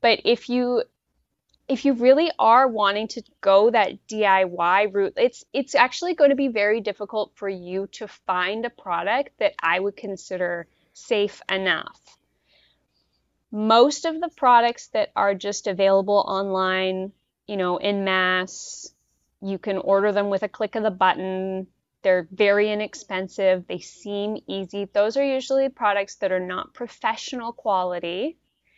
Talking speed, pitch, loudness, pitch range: 150 wpm, 205 Hz, -22 LUFS, 190-240 Hz